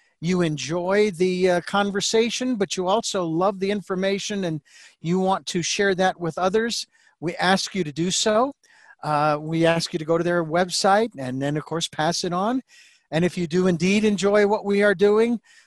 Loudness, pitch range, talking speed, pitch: -22 LUFS, 170-205 Hz, 190 wpm, 185 Hz